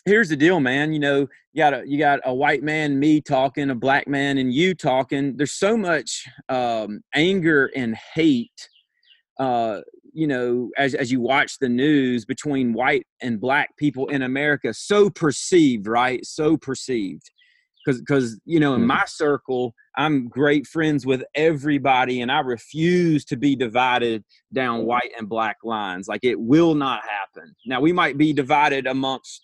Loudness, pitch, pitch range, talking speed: -21 LUFS, 140 Hz, 130-155 Hz, 170 wpm